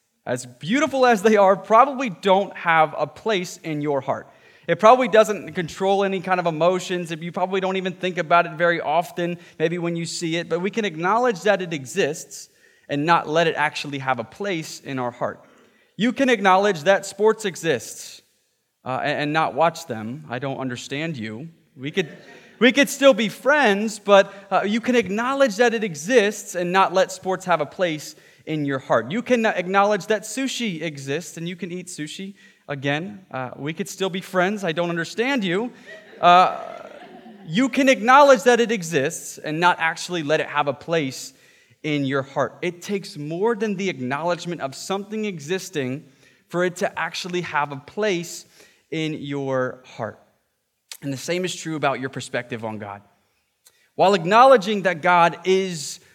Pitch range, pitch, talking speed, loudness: 150-205 Hz, 175 Hz, 180 wpm, -21 LUFS